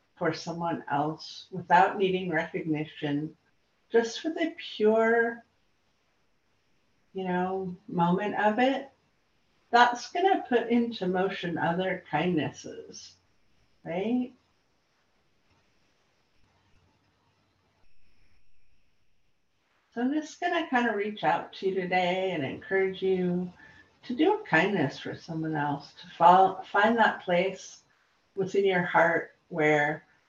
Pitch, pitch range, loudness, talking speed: 180 Hz, 150-215 Hz, -27 LUFS, 105 wpm